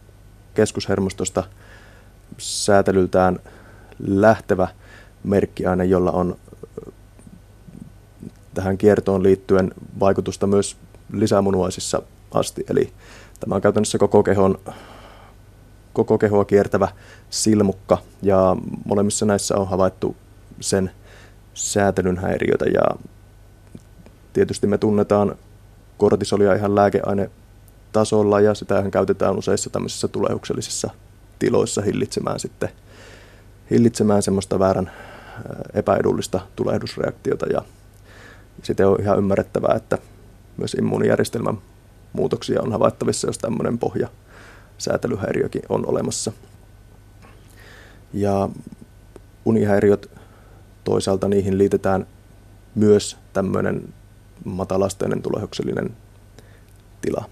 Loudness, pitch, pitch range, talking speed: -20 LUFS, 100 Hz, 95-105 Hz, 80 wpm